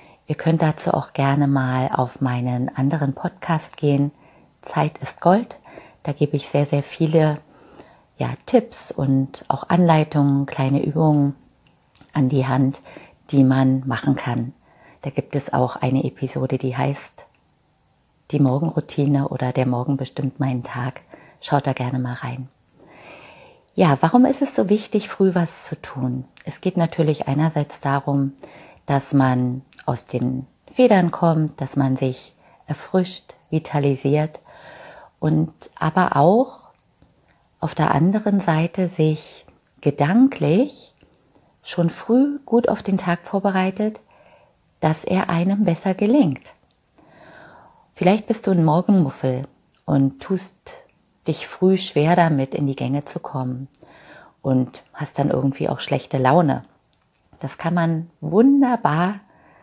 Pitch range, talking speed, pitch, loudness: 135-180 Hz, 130 wpm, 150 Hz, -21 LUFS